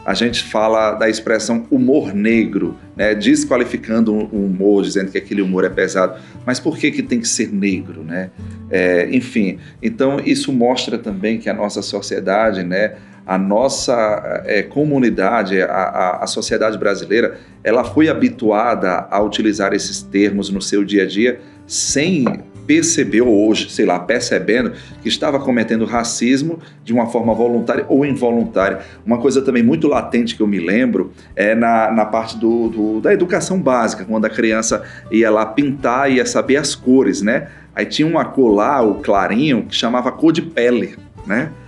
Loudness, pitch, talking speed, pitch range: -16 LUFS, 115 Hz, 170 wpm, 100-130 Hz